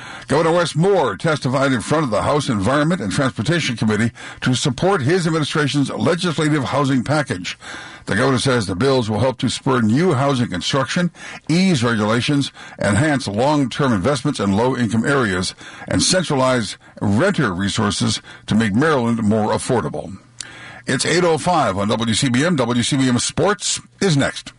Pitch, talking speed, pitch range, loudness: 130 Hz, 140 wpm, 115-150 Hz, -18 LUFS